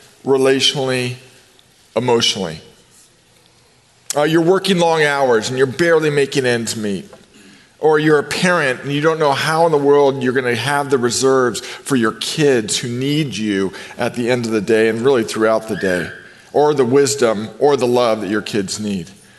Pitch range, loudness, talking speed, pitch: 115-145 Hz, -16 LUFS, 180 wpm, 130 Hz